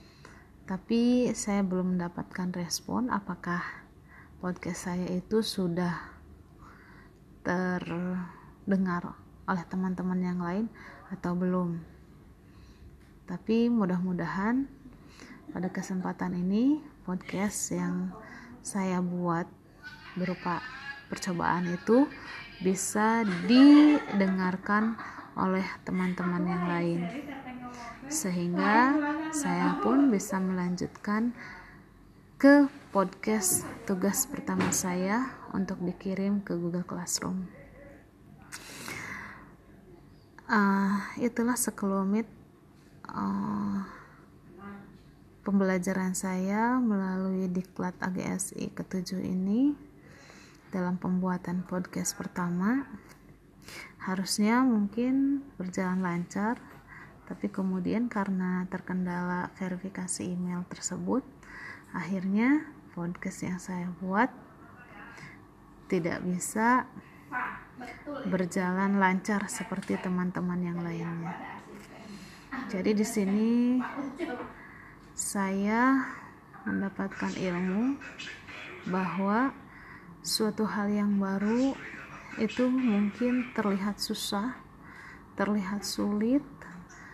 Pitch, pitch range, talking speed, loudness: 190 Hz, 180-220 Hz, 75 wpm, -30 LUFS